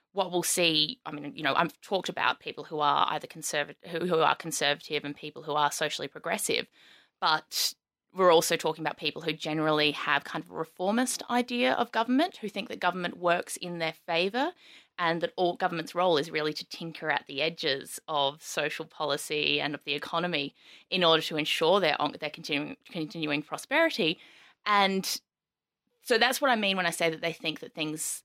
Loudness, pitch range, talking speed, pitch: -28 LUFS, 150-185 Hz, 195 wpm, 165 Hz